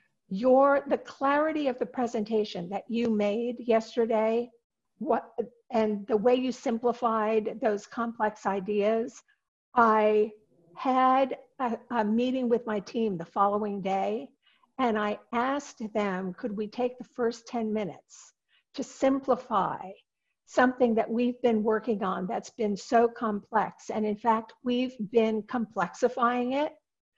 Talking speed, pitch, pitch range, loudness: 130 wpm, 230 Hz, 215-250 Hz, -28 LUFS